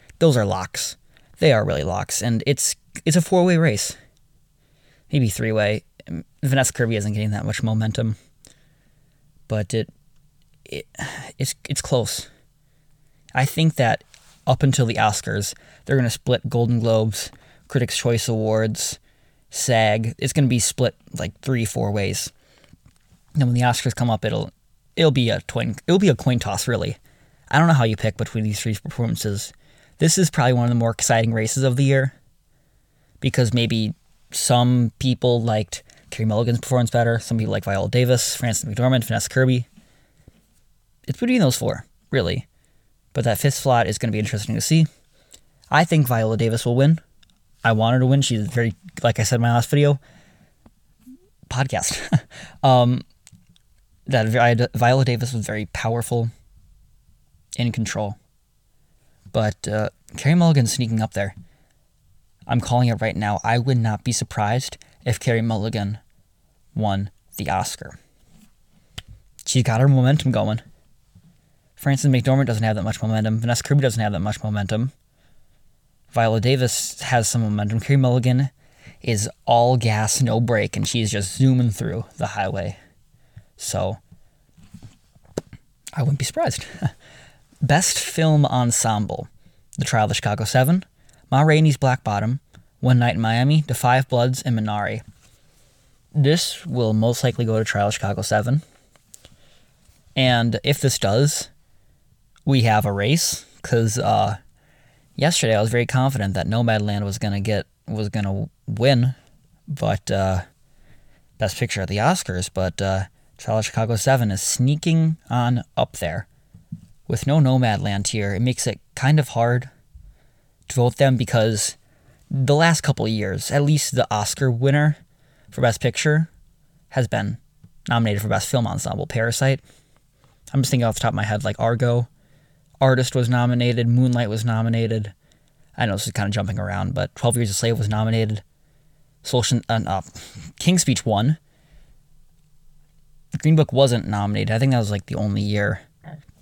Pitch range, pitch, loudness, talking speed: 110-140 Hz, 120 Hz, -21 LUFS, 155 wpm